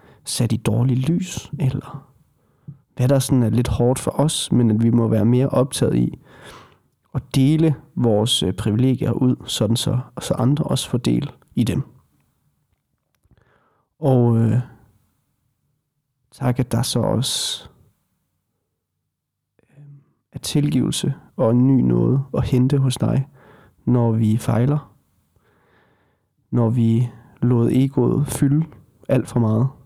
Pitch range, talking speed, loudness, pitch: 115-140 Hz, 130 wpm, -20 LUFS, 125 Hz